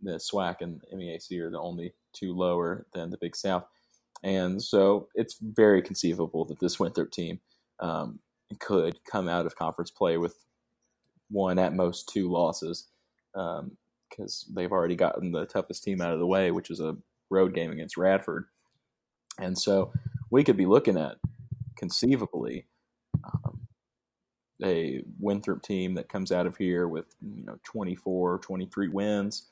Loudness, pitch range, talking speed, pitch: -29 LUFS, 85-100 Hz, 155 wpm, 95 Hz